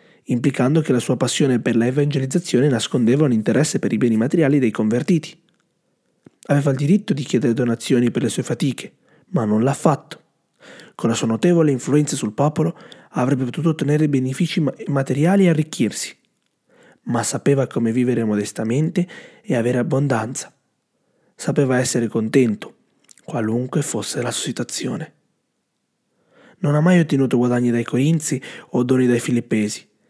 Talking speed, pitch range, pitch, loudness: 140 wpm, 120-160 Hz, 135 Hz, -19 LUFS